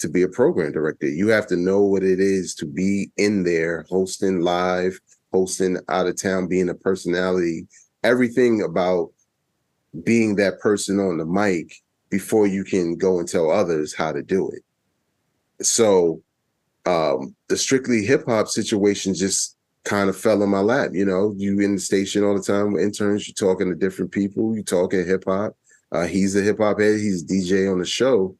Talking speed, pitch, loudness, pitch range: 185 wpm, 95 Hz, -21 LUFS, 90-100 Hz